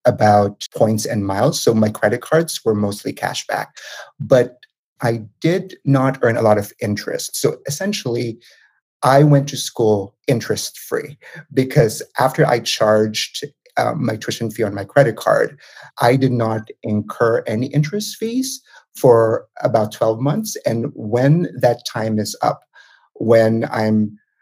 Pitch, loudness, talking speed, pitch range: 120 Hz, -18 LUFS, 145 wpm, 110-145 Hz